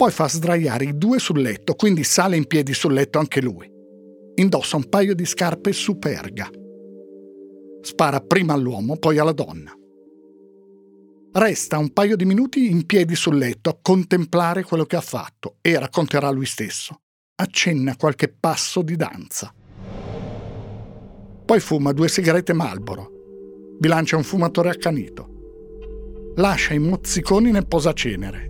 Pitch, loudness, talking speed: 150 Hz, -20 LUFS, 135 wpm